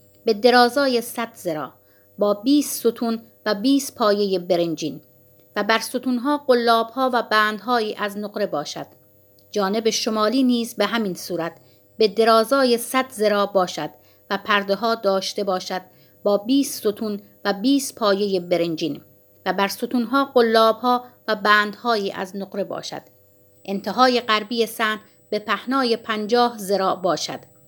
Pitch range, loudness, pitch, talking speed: 190-235 Hz, -21 LUFS, 215 Hz, 130 wpm